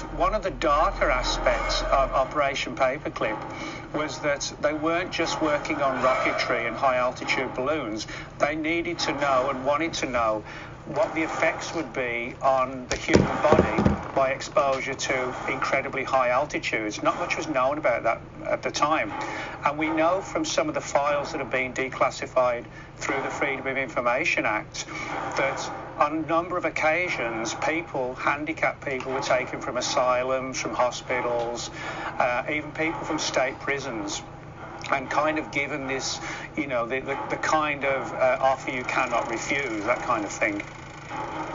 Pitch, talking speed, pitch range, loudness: 135 Hz, 160 wpm, 130-155 Hz, -26 LUFS